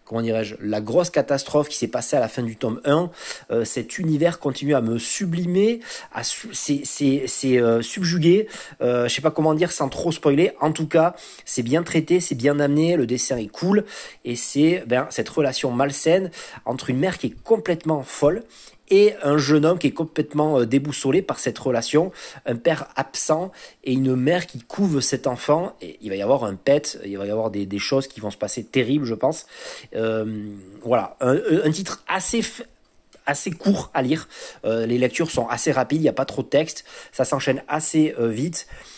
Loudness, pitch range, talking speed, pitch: -22 LUFS, 125-165 Hz, 205 wpm, 145 Hz